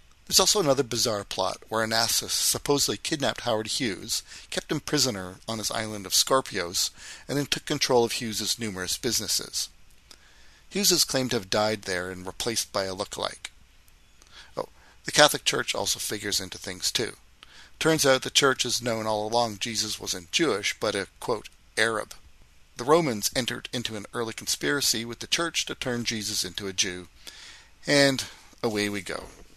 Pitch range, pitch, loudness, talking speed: 100-130 Hz, 115 Hz, -26 LUFS, 170 wpm